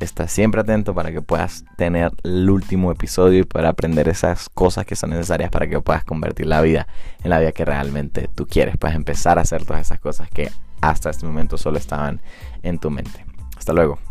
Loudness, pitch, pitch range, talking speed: -20 LUFS, 80 Hz, 75-90 Hz, 210 wpm